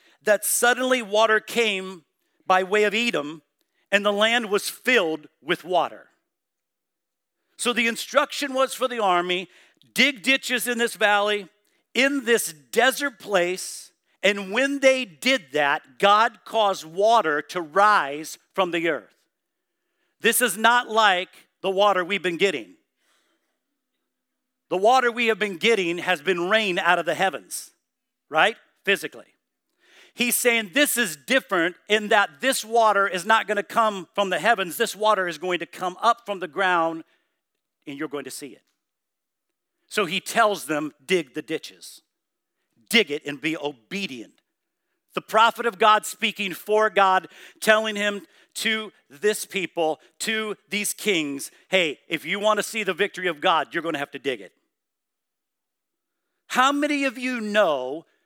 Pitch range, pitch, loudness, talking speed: 180-235 Hz, 205 Hz, -22 LUFS, 150 wpm